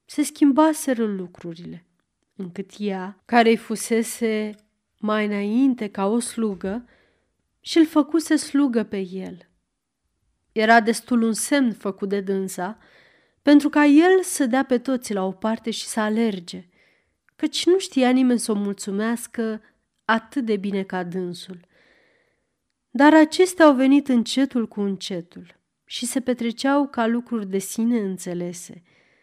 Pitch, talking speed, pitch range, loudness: 225 Hz, 135 wpm, 200-270 Hz, -21 LUFS